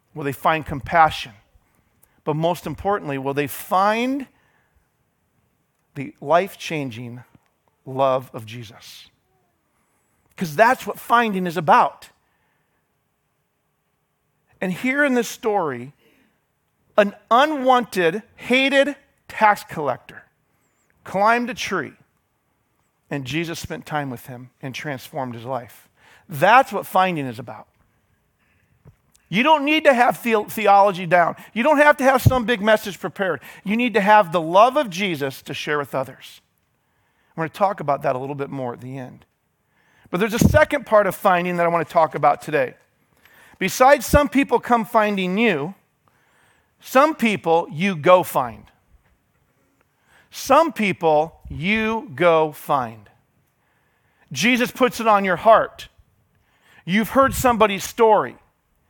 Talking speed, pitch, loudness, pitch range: 135 wpm, 175 Hz, -19 LUFS, 135-220 Hz